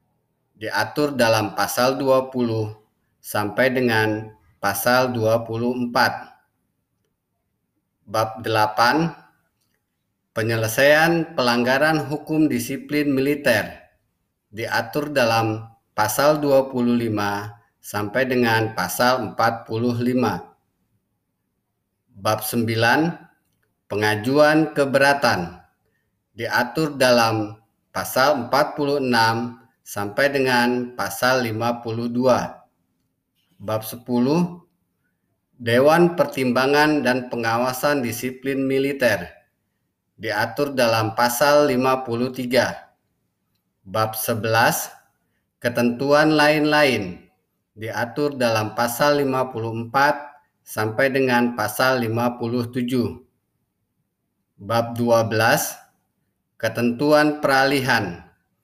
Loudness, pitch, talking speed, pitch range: -20 LUFS, 120 Hz, 65 wpm, 110-135 Hz